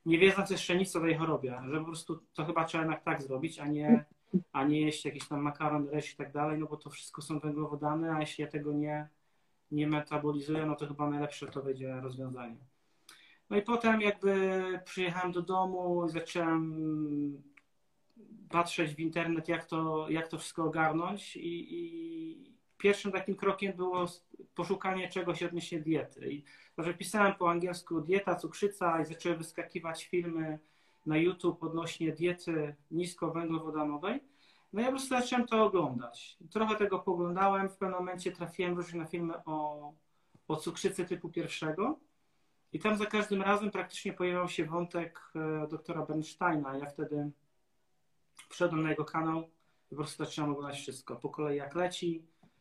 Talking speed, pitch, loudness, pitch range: 160 wpm, 165 Hz, -34 LUFS, 150-185 Hz